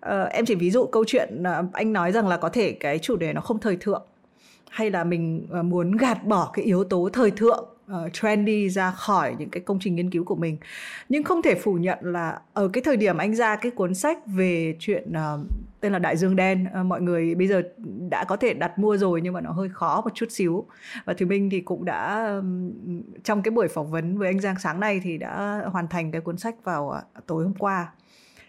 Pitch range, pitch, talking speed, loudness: 175-210 Hz, 190 Hz, 245 wpm, -25 LUFS